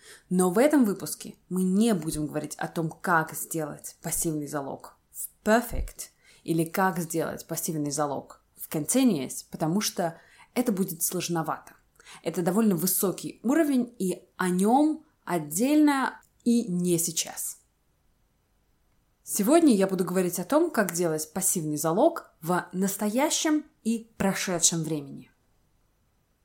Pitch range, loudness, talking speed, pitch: 165-225 Hz, -26 LUFS, 120 wpm, 185 Hz